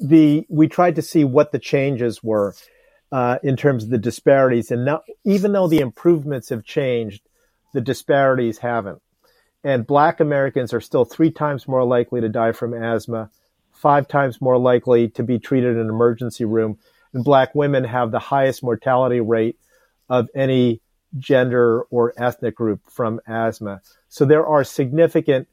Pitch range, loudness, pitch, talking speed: 115-145 Hz, -19 LUFS, 125 Hz, 165 wpm